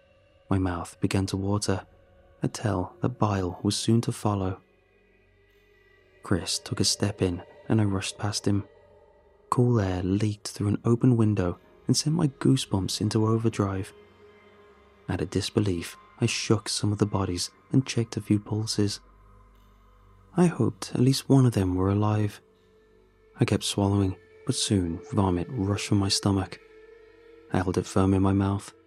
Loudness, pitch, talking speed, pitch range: -26 LUFS, 105 Hz, 160 wpm, 95-115 Hz